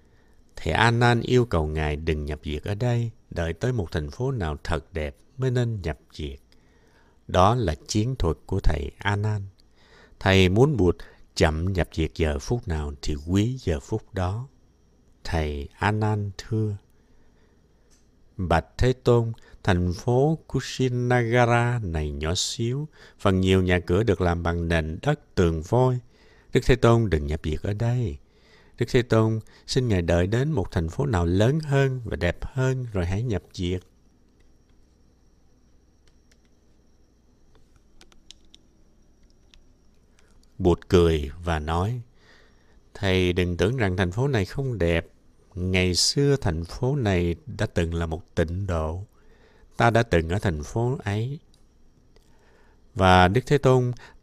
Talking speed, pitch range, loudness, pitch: 145 wpm, 80-120 Hz, -24 LUFS, 95 Hz